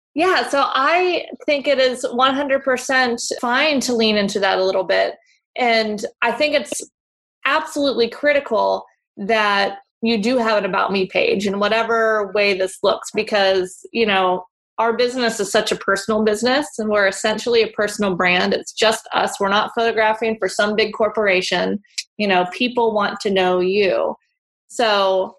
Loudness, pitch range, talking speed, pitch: -18 LUFS, 200-245 Hz, 160 wpm, 220 Hz